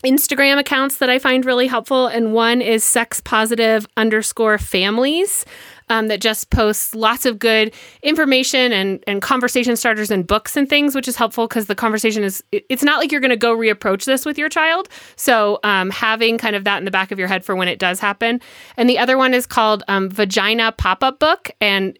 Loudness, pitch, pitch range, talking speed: -16 LUFS, 230 Hz, 215-265 Hz, 210 wpm